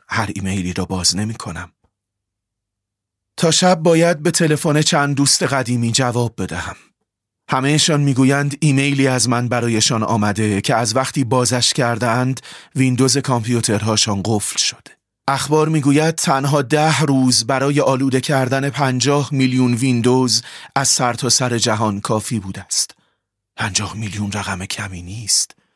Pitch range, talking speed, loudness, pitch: 105-140 Hz, 130 wpm, -16 LUFS, 125 Hz